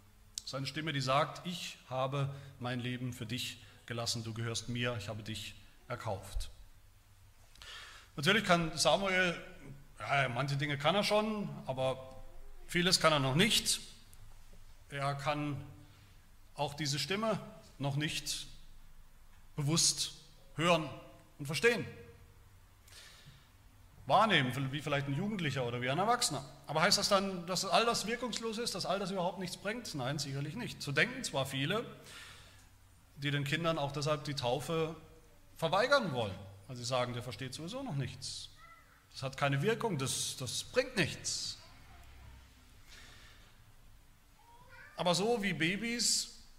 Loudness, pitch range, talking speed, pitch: -34 LUFS, 115-170 Hz, 135 wpm, 140 Hz